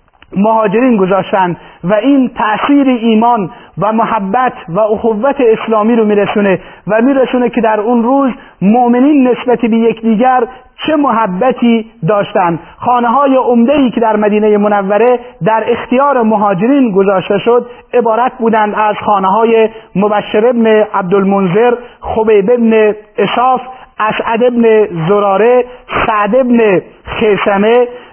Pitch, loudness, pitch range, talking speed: 225 Hz, -10 LUFS, 210-245 Hz, 120 wpm